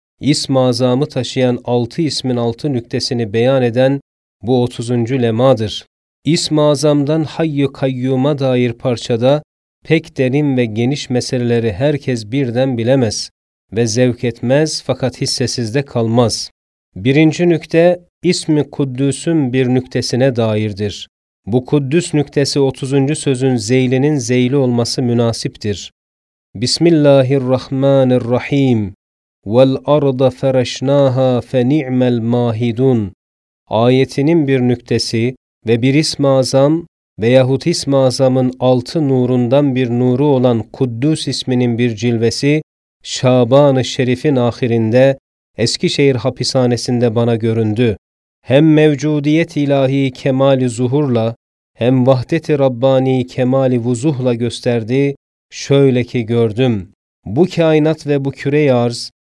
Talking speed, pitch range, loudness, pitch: 100 wpm, 120-140 Hz, -14 LUFS, 130 Hz